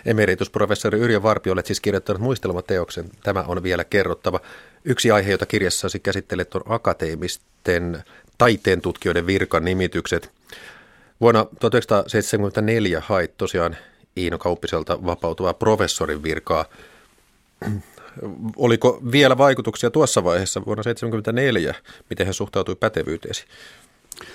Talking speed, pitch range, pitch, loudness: 105 wpm, 90-115 Hz, 100 Hz, -21 LUFS